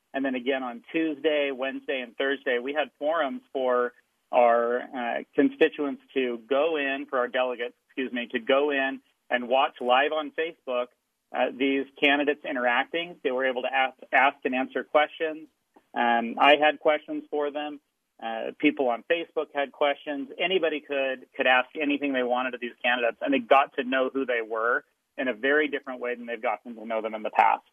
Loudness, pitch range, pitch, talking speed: -26 LUFS, 125-150 Hz, 135 Hz, 190 wpm